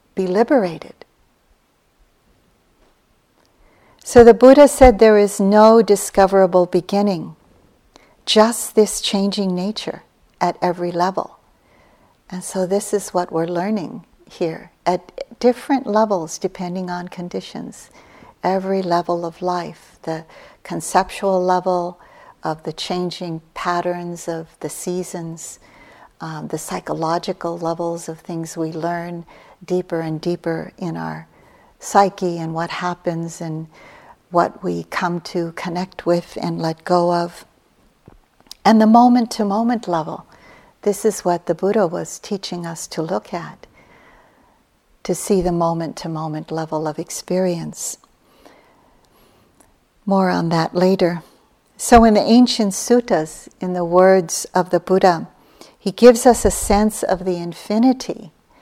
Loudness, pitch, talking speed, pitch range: -18 LUFS, 180 Hz, 125 wpm, 170-205 Hz